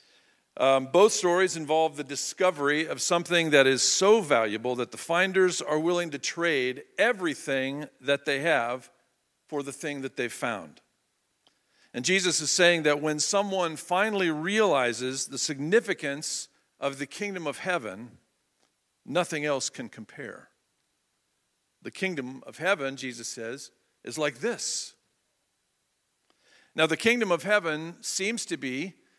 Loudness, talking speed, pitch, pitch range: -26 LUFS, 135 wpm, 155 Hz, 140-185 Hz